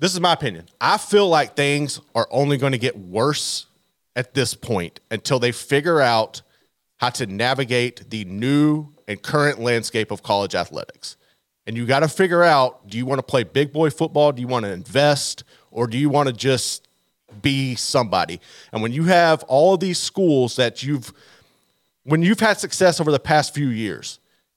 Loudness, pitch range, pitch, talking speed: -20 LUFS, 120-150 Hz, 135 Hz, 190 wpm